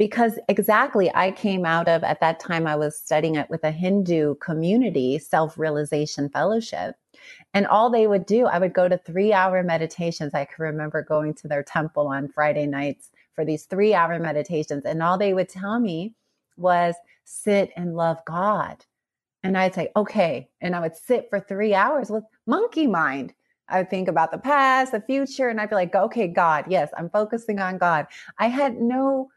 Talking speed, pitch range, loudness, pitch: 185 wpm, 155-210 Hz, -23 LUFS, 180 Hz